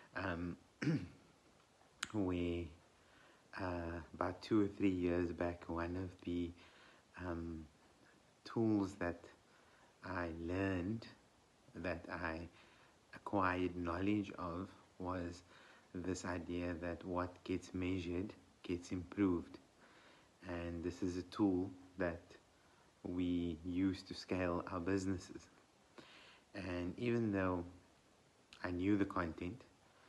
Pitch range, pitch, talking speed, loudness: 85-95 Hz, 90 Hz, 100 wpm, -42 LUFS